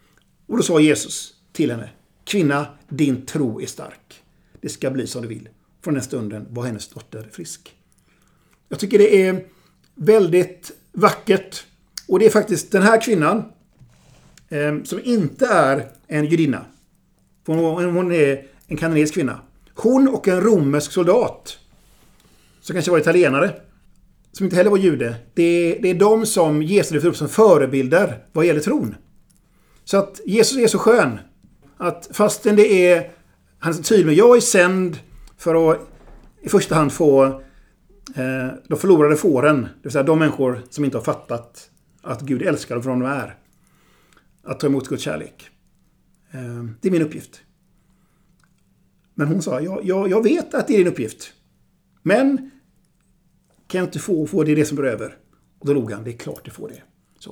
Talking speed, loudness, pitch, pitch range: 160 wpm, -18 LUFS, 165 Hz, 140-195 Hz